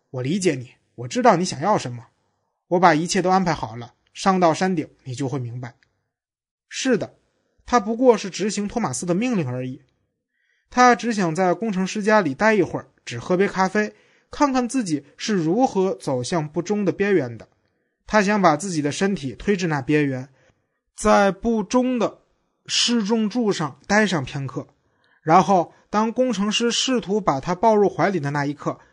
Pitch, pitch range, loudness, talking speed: 180 Hz, 140-215 Hz, -21 LUFS, 255 characters per minute